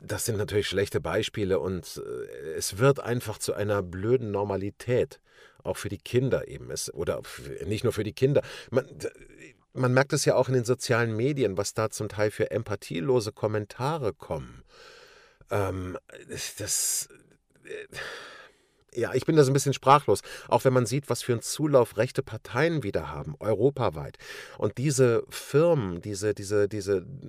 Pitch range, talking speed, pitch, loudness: 105-140 Hz, 160 wpm, 120 Hz, -27 LUFS